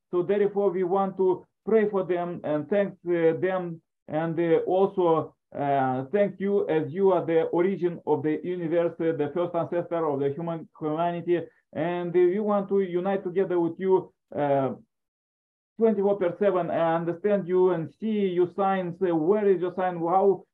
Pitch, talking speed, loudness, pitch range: 175 Hz, 160 wpm, -26 LUFS, 165-195 Hz